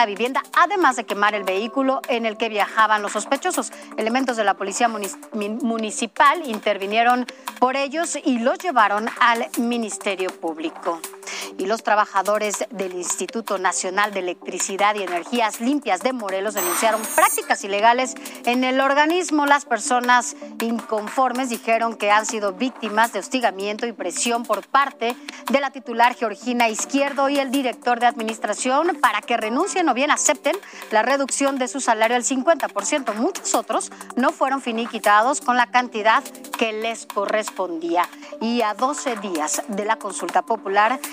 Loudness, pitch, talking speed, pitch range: -21 LUFS, 235 Hz, 150 wpm, 210-275 Hz